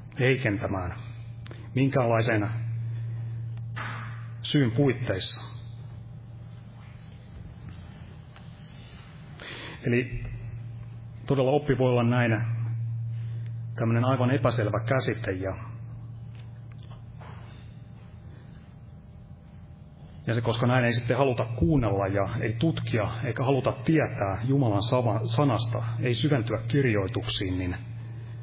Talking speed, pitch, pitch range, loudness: 75 wpm, 115 Hz, 115-125 Hz, -27 LUFS